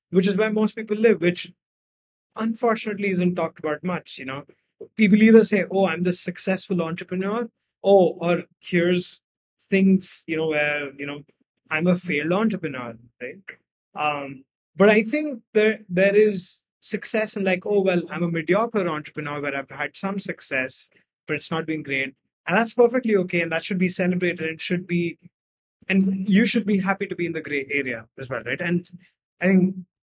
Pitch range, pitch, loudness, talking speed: 155-200 Hz, 180 Hz, -22 LUFS, 180 wpm